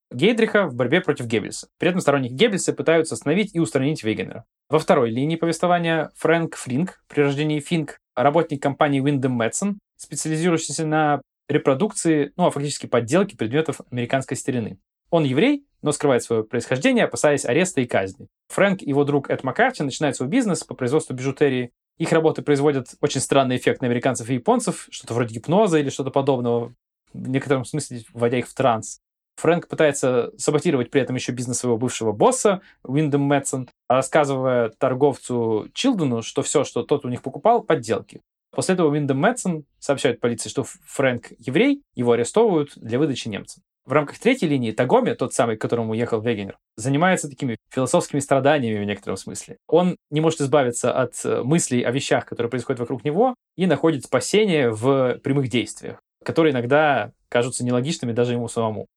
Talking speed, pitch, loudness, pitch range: 165 wpm, 140 Hz, -21 LUFS, 125-160 Hz